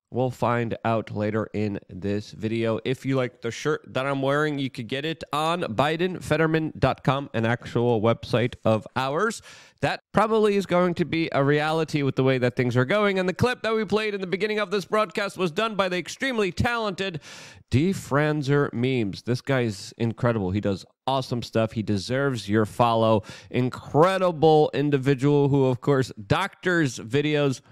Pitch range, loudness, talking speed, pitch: 120-165 Hz, -24 LUFS, 170 wpm, 135 Hz